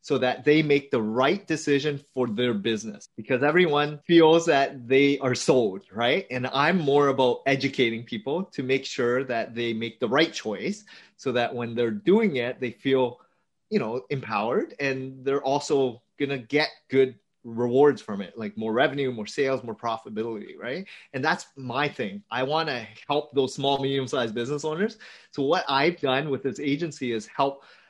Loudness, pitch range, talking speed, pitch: -25 LUFS, 120-145 Hz, 185 wpm, 135 Hz